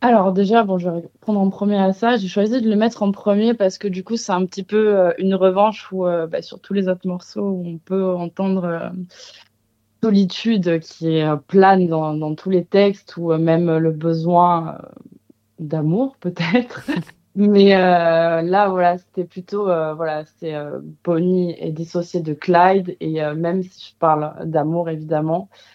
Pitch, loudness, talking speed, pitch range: 180 Hz, -19 LUFS, 190 wpm, 165-195 Hz